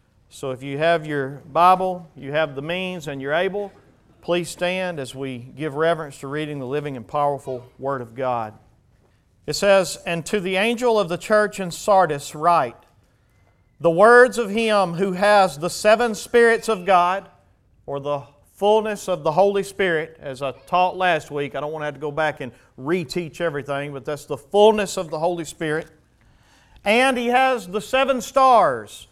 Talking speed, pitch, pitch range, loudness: 180 wpm, 165 Hz, 140-195 Hz, -20 LUFS